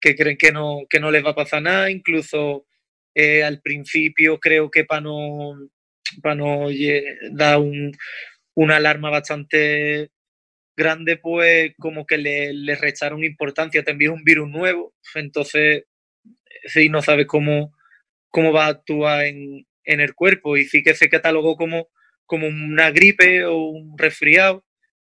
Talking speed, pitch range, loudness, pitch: 155 wpm, 150-160 Hz, -17 LUFS, 150 Hz